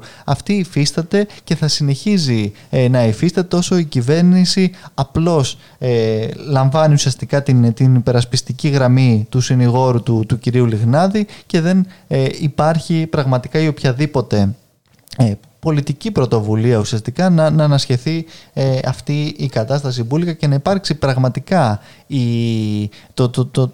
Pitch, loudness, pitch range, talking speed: 135 Hz, -16 LUFS, 125-160 Hz, 140 wpm